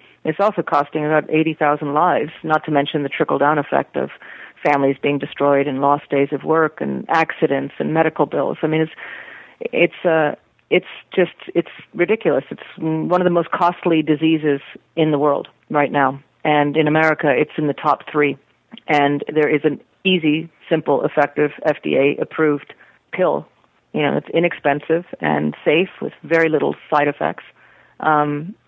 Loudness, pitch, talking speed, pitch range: -18 LUFS, 150 Hz, 165 wpm, 145-160 Hz